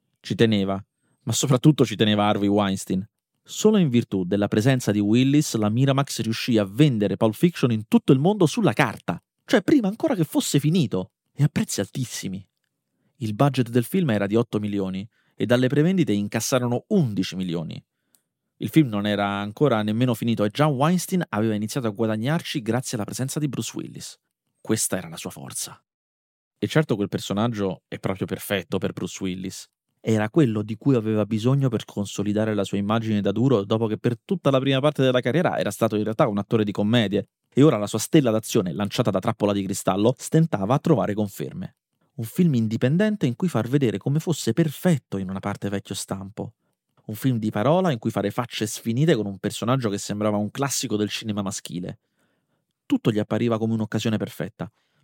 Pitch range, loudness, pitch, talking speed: 105-140 Hz, -23 LUFS, 115 Hz, 190 wpm